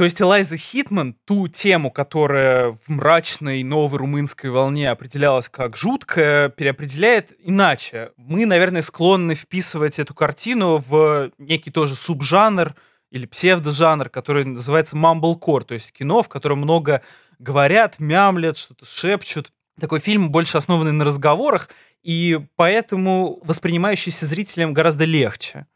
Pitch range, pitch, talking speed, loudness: 145-180 Hz, 160 Hz, 125 wpm, -18 LUFS